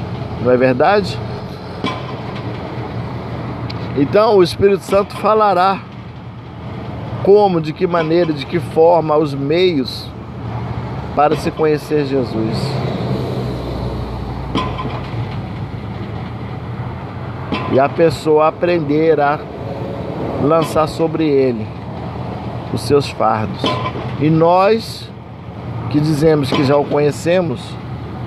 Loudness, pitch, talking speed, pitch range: -17 LUFS, 145 Hz, 85 wpm, 120-165 Hz